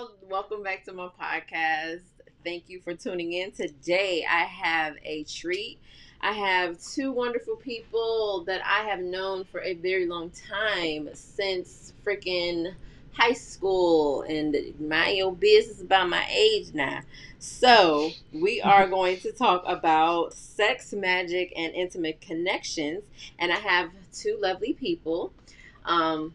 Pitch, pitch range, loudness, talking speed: 185 Hz, 170-205 Hz, -26 LUFS, 135 wpm